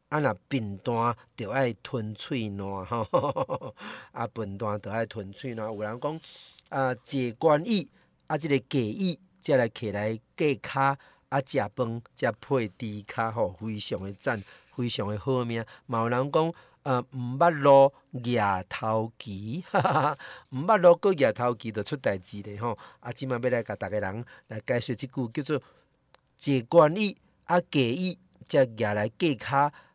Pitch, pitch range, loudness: 125 Hz, 110-140 Hz, -28 LUFS